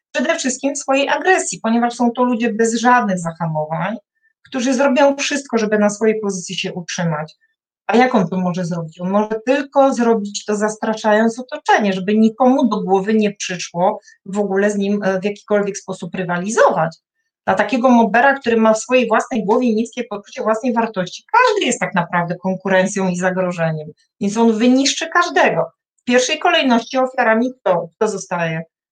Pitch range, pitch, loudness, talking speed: 190-255 Hz, 220 Hz, -17 LUFS, 160 wpm